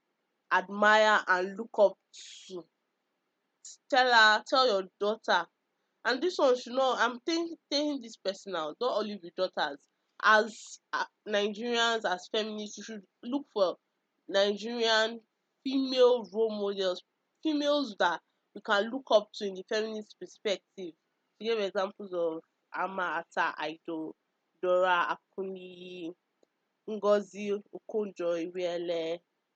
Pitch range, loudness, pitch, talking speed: 185-230 Hz, -30 LUFS, 210 Hz, 120 wpm